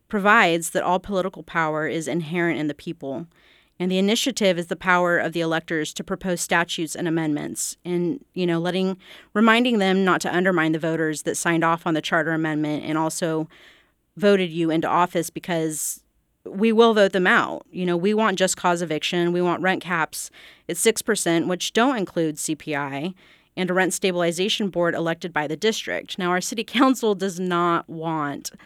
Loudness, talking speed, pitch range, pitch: -22 LUFS, 180 wpm, 165-190 Hz, 175 Hz